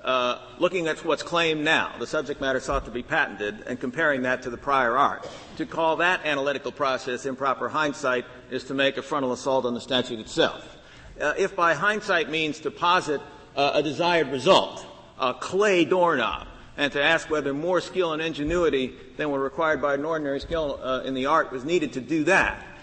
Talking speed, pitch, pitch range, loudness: 195 wpm, 145 Hz, 130-165 Hz, -24 LUFS